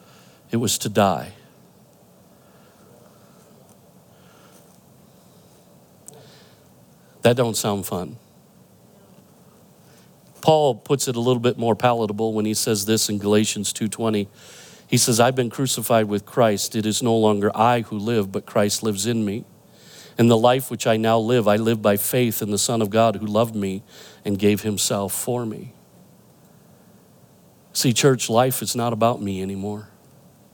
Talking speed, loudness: 145 wpm, -21 LUFS